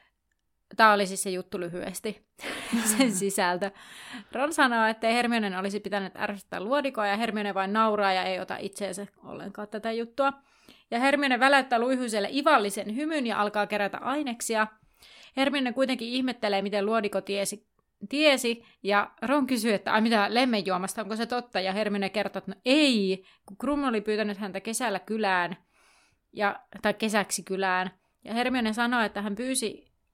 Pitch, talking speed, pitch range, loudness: 215 Hz, 155 wpm, 200-245 Hz, -27 LUFS